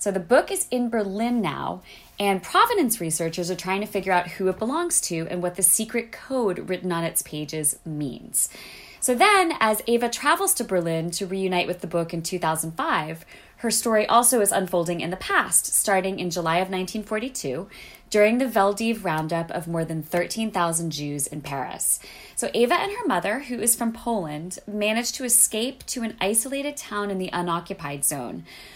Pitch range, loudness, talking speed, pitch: 170-235 Hz, -23 LUFS, 180 wpm, 195 Hz